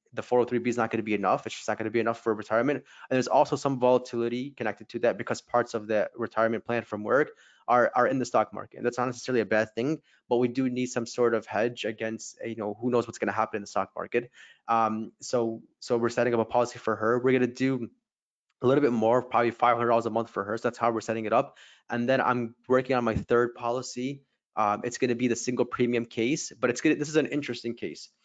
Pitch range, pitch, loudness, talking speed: 115-125 Hz, 120 Hz, -28 LUFS, 265 wpm